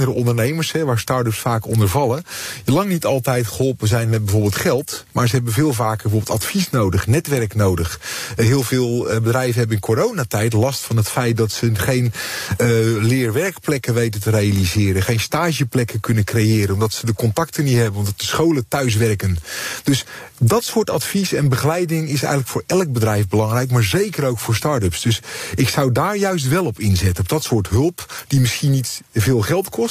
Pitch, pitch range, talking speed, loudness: 120 Hz, 110-140 Hz, 185 wpm, -18 LUFS